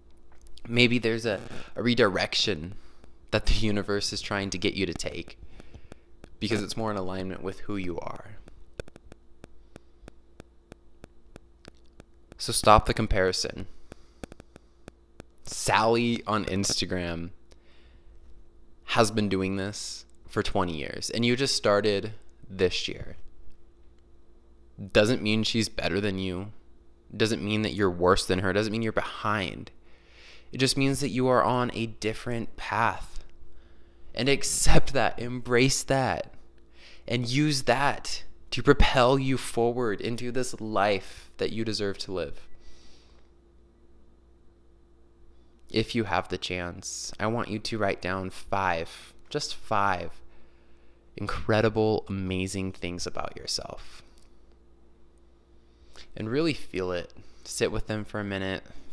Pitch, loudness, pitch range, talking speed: 95 Hz, -27 LUFS, 85-110 Hz, 120 wpm